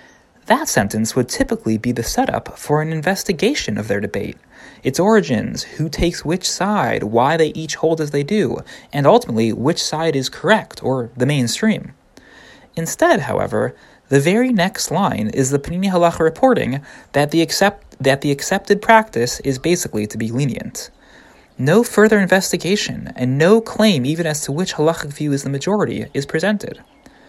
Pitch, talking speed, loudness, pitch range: 160 Hz, 165 wpm, -17 LUFS, 135-200 Hz